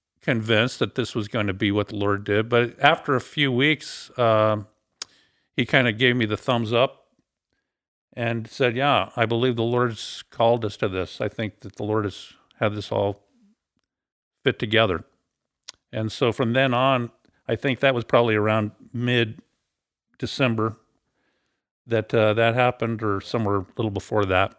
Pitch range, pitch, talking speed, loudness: 105-125 Hz, 115 Hz, 170 wpm, -23 LUFS